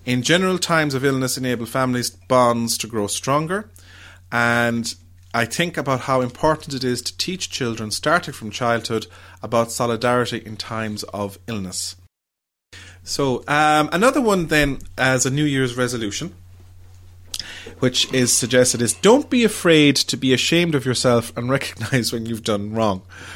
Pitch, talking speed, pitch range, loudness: 120 Hz, 150 wpm, 105-135 Hz, -20 LUFS